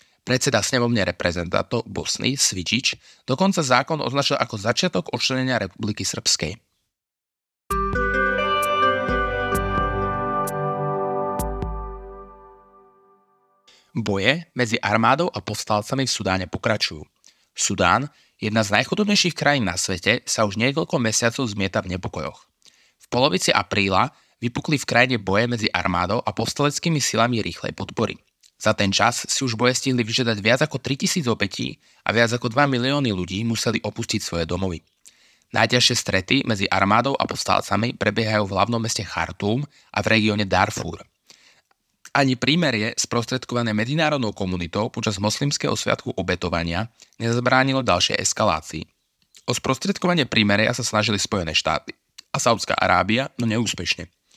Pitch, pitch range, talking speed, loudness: 110 Hz, 100-130 Hz, 120 wpm, -21 LUFS